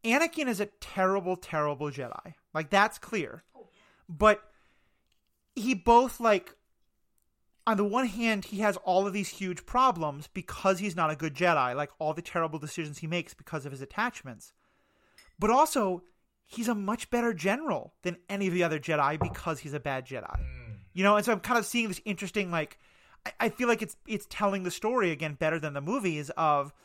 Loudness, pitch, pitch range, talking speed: -29 LUFS, 185 Hz, 155-215 Hz, 190 wpm